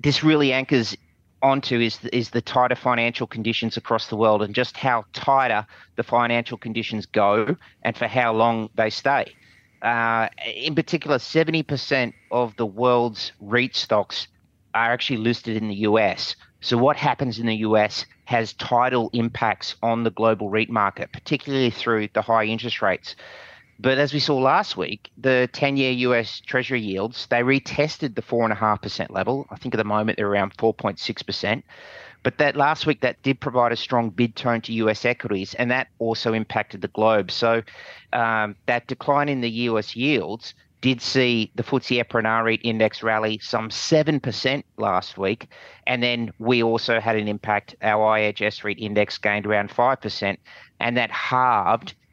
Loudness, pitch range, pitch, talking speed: -22 LUFS, 110-125 Hz, 115 Hz, 180 wpm